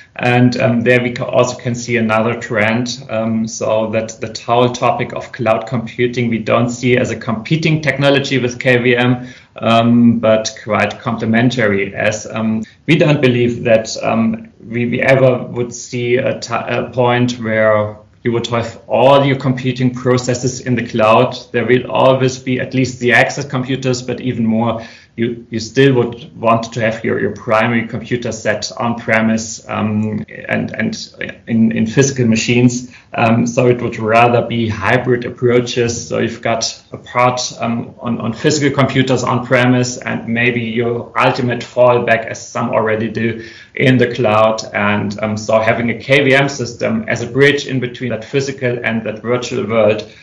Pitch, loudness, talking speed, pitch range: 120 Hz, -15 LUFS, 170 wpm, 115-125 Hz